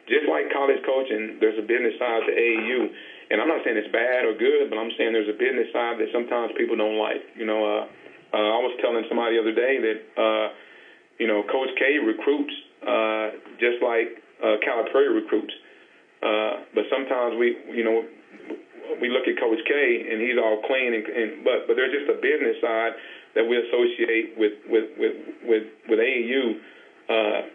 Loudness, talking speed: -24 LUFS, 190 wpm